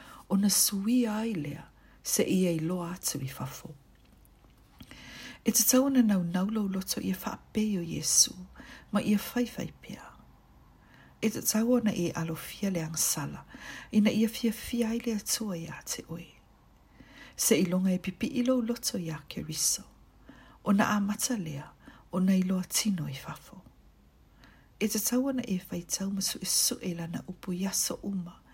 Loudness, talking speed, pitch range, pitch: -29 LUFS, 170 wpm, 170-220 Hz, 195 Hz